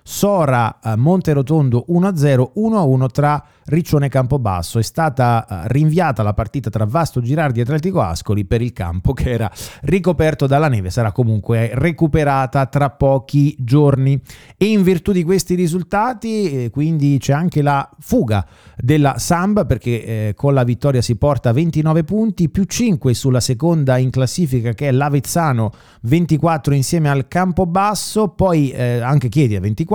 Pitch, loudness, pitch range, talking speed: 140 Hz, -16 LUFS, 120-165 Hz, 150 wpm